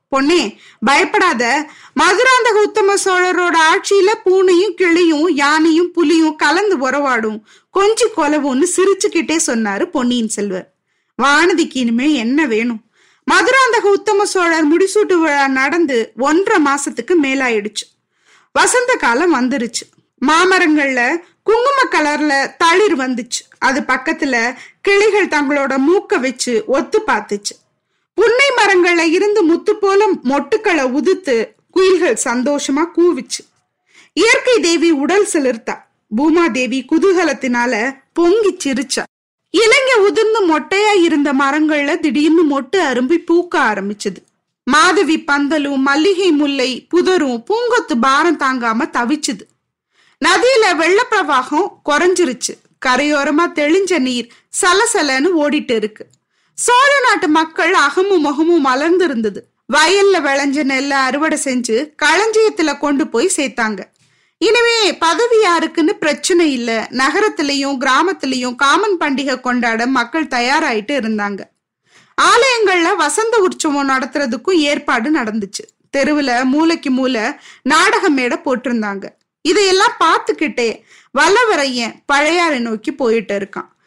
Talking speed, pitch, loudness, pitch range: 100 wpm, 315 Hz, -14 LUFS, 265-370 Hz